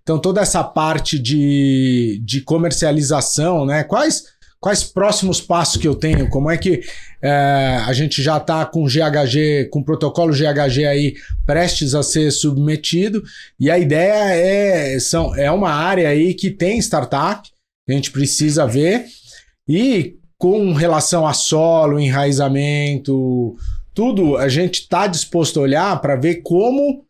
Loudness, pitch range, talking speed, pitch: -16 LUFS, 140-175 Hz, 145 wpm, 155 Hz